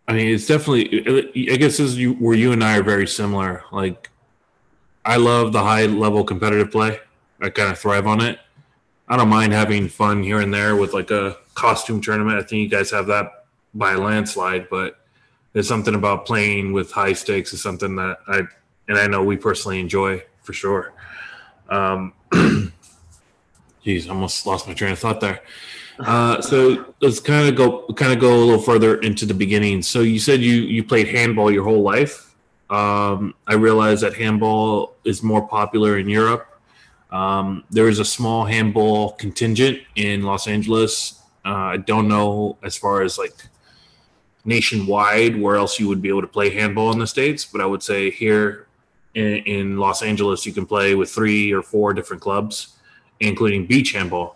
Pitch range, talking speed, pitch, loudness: 100-110 Hz, 185 wpm, 105 Hz, -18 LUFS